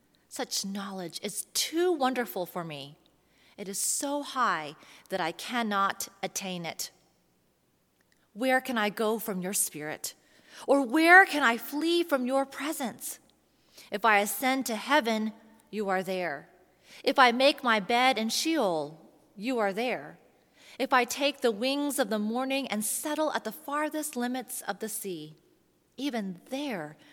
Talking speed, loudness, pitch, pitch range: 150 wpm, -28 LUFS, 240 Hz, 200-270 Hz